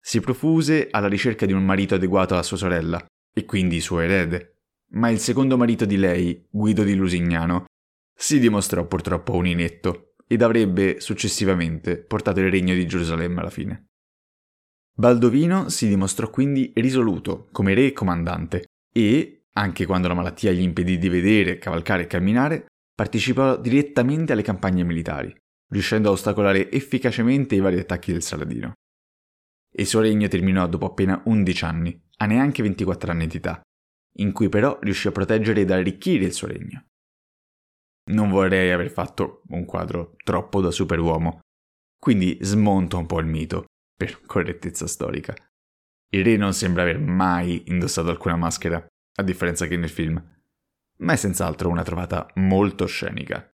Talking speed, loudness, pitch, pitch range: 155 wpm, -22 LUFS, 95 Hz, 85-105 Hz